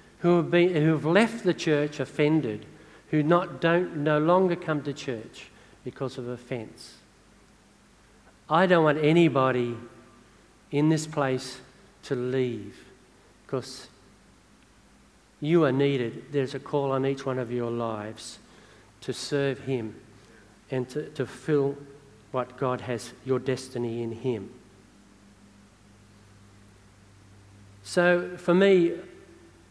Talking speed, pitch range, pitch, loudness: 125 wpm, 110-150 Hz, 130 Hz, -26 LUFS